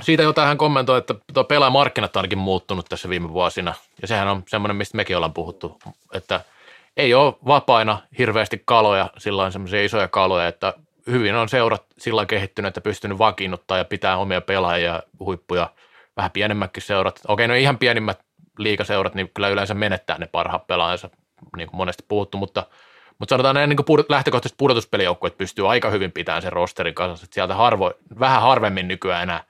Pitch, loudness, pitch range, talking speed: 100 Hz, -20 LUFS, 95-125 Hz, 175 wpm